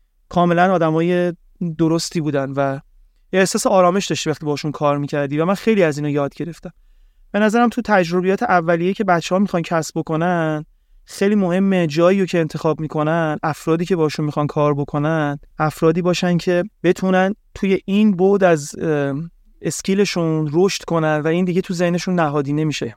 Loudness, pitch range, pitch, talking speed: -18 LUFS, 155-185 Hz, 170 Hz, 160 wpm